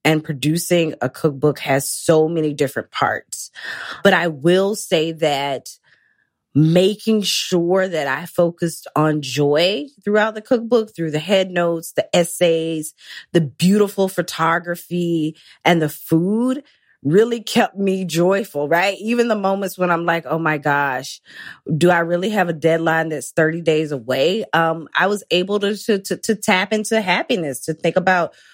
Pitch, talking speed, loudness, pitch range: 170 Hz, 155 wpm, -18 LUFS, 155-195 Hz